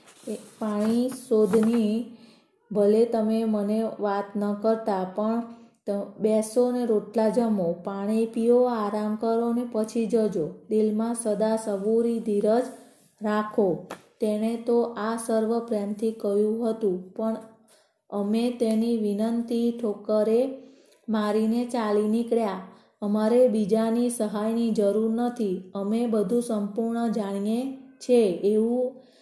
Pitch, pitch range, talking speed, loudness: 225 Hz, 210-235 Hz, 105 wpm, -25 LUFS